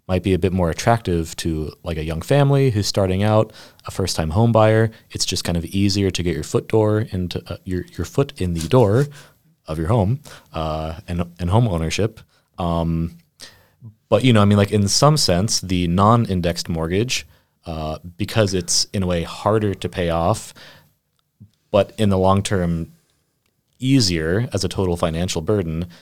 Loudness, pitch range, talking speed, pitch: -20 LUFS, 85-110 Hz, 180 wpm, 95 Hz